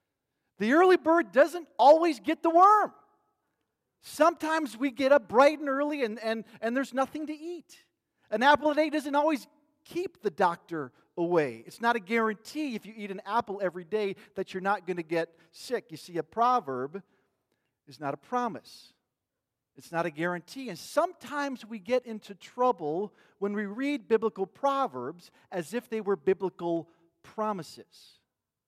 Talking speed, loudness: 165 wpm, -28 LUFS